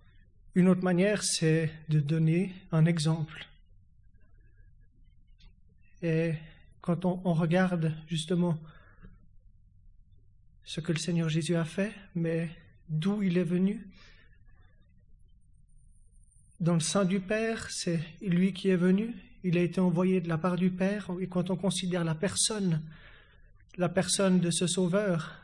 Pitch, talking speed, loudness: 165 Hz, 130 wpm, -29 LUFS